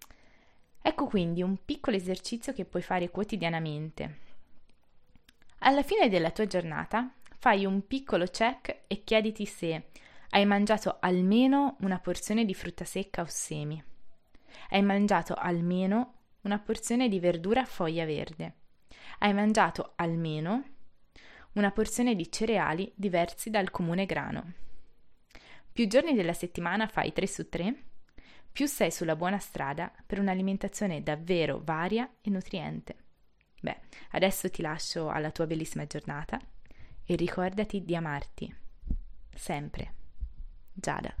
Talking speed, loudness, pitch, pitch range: 125 wpm, -30 LUFS, 185 Hz, 165-215 Hz